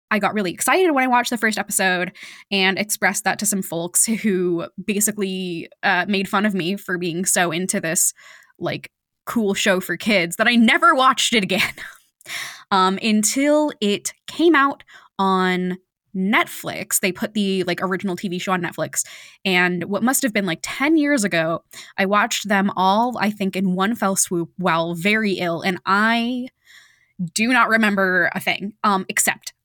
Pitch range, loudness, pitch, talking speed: 185-220 Hz, -19 LUFS, 195 Hz, 175 wpm